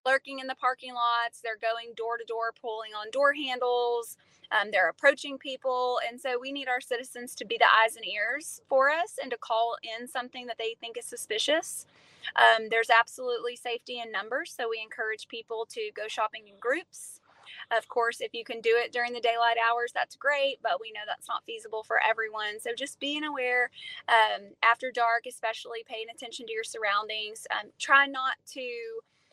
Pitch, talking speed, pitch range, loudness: 240 Hz, 195 wpm, 230-265 Hz, -29 LUFS